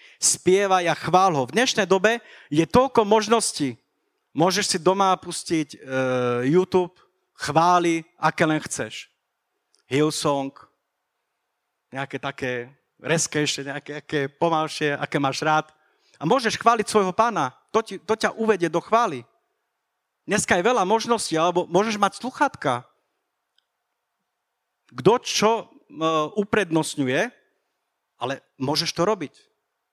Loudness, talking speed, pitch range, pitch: -22 LUFS, 110 wpm, 150-215 Hz, 170 Hz